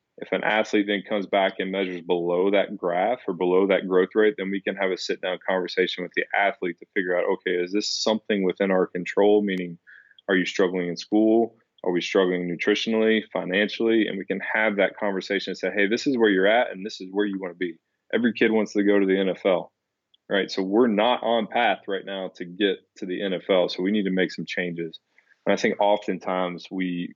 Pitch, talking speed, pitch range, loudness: 95 Hz, 230 wpm, 90-105 Hz, -24 LUFS